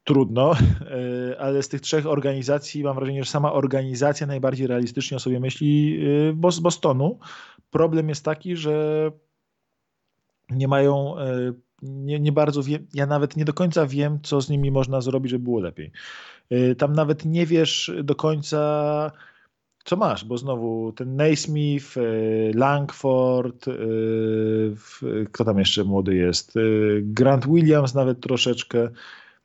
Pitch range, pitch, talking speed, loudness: 125-150 Hz, 135 Hz, 130 wpm, -22 LUFS